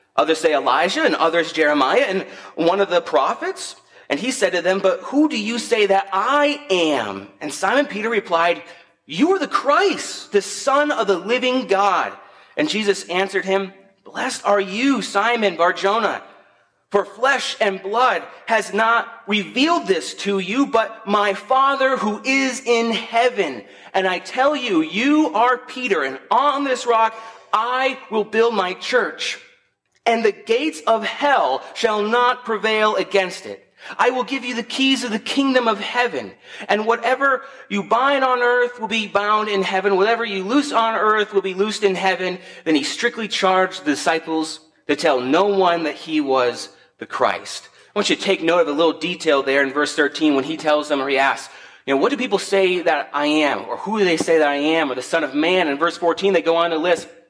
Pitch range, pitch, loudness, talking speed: 165-235 Hz, 200 Hz, -19 LUFS, 195 wpm